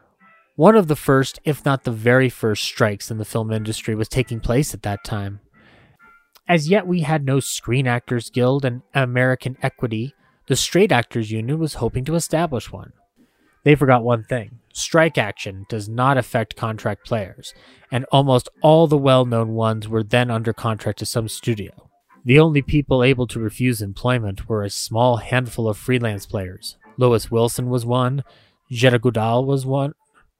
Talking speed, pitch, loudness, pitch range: 170 wpm, 125 Hz, -19 LUFS, 110-135 Hz